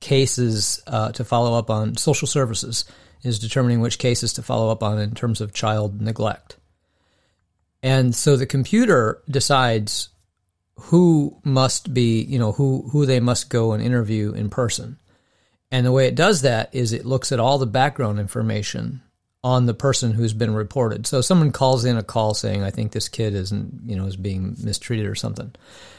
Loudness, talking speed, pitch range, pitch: -21 LUFS, 180 wpm, 105-130 Hz, 115 Hz